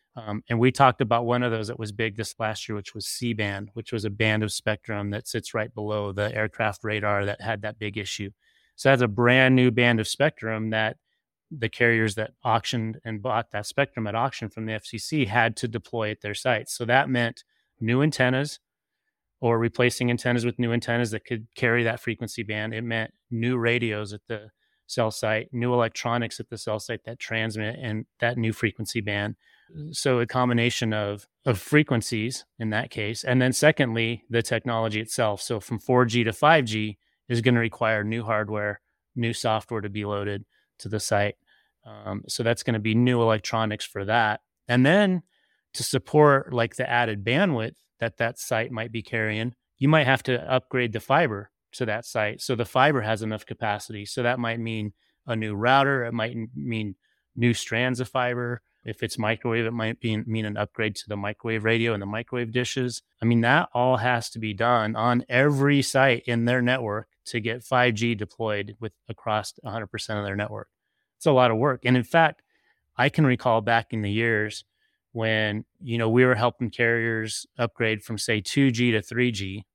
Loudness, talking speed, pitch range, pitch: -25 LUFS, 195 wpm, 110-125 Hz, 115 Hz